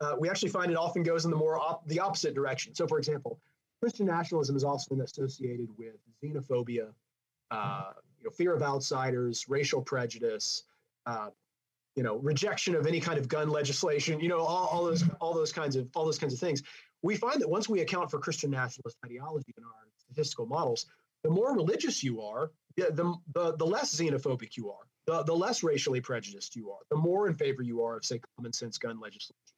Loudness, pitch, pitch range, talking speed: -32 LUFS, 150 Hz, 125-165 Hz, 205 wpm